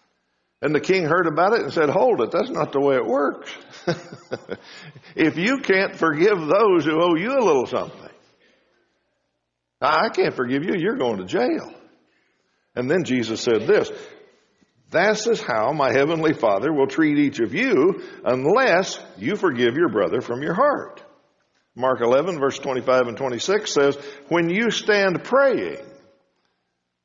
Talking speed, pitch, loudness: 155 wpm, 175 Hz, -20 LUFS